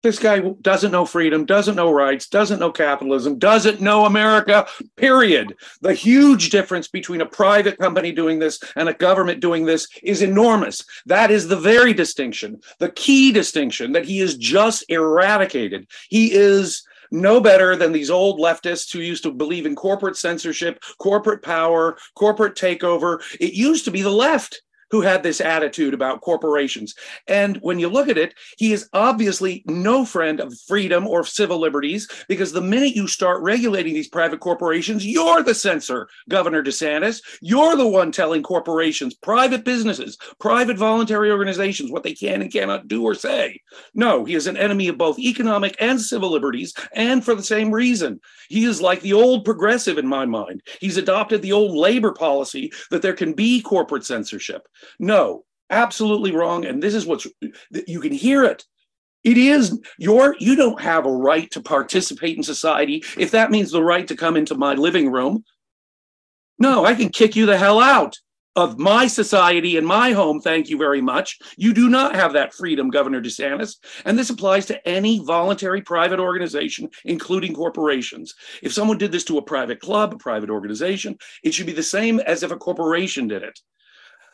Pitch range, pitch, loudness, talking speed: 165-220 Hz, 195 Hz, -18 LUFS, 180 wpm